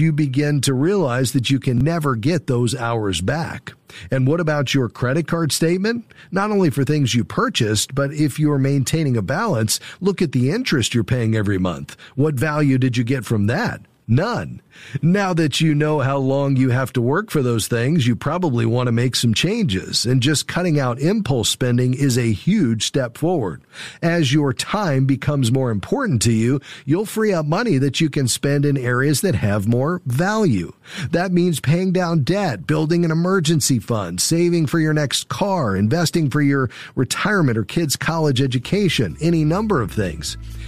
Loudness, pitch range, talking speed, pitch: -19 LUFS, 125-165 Hz, 185 wpm, 140 Hz